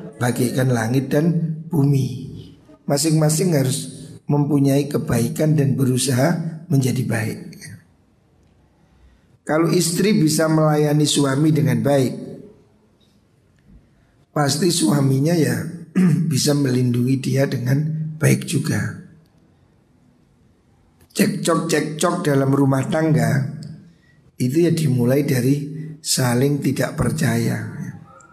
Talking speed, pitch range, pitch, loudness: 85 wpm, 135-160 Hz, 145 Hz, -19 LUFS